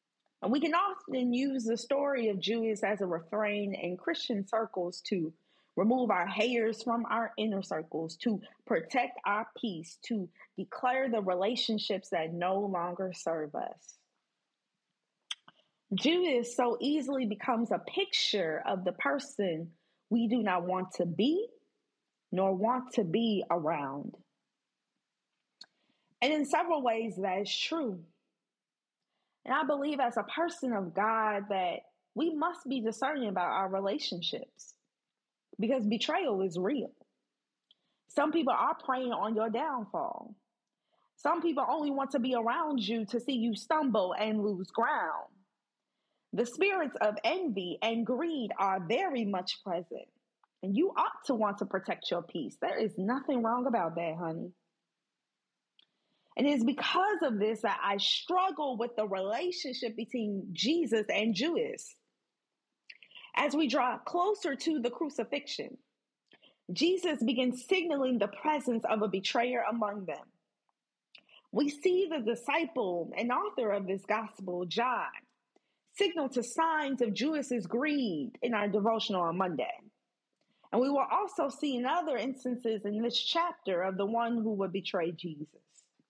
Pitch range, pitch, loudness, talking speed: 200-280 Hz, 235 Hz, -32 LUFS, 140 wpm